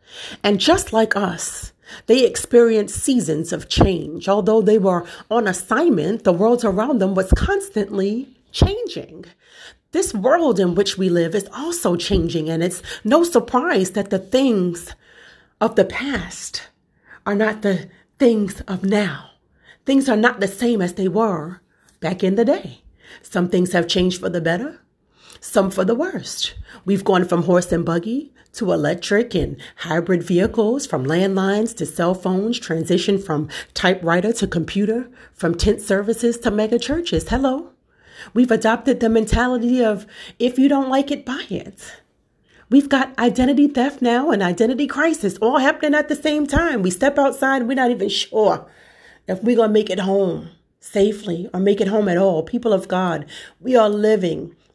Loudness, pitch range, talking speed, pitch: -19 LUFS, 185-245 Hz, 165 wpm, 210 Hz